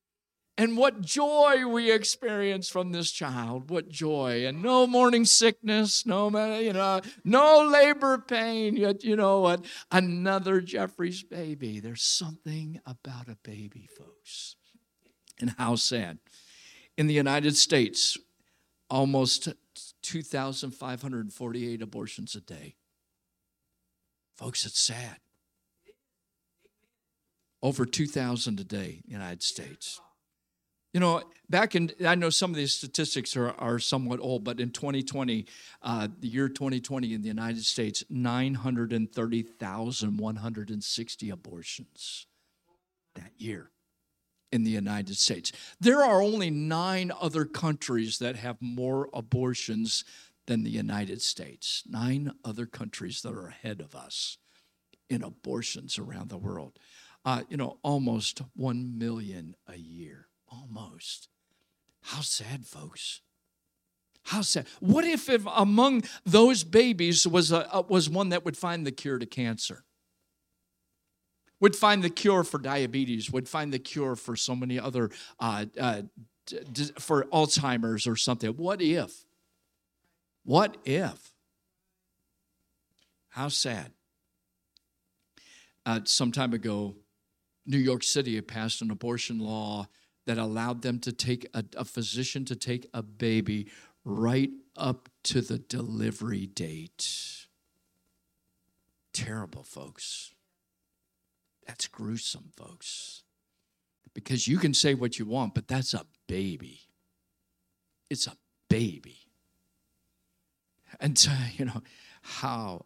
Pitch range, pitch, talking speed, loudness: 110-165 Hz, 125 Hz, 125 wpm, -28 LUFS